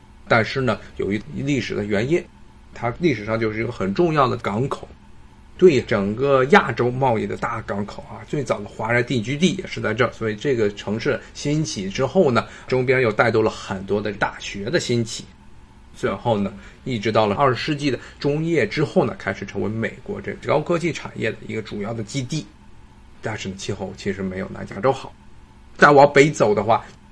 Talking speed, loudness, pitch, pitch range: 290 characters per minute, -21 LUFS, 120 Hz, 110-140 Hz